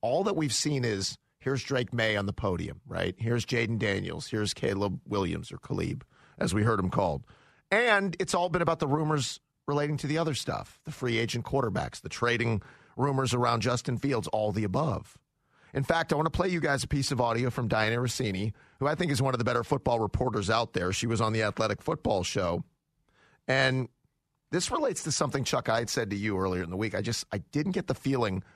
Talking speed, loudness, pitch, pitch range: 225 wpm, -29 LUFS, 125 Hz, 110-145 Hz